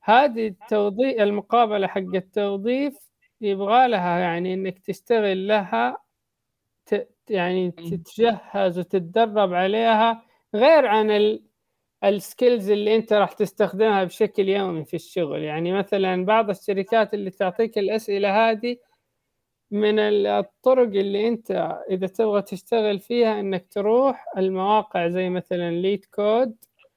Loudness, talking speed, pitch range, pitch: -22 LUFS, 110 wpm, 190-225 Hz, 205 Hz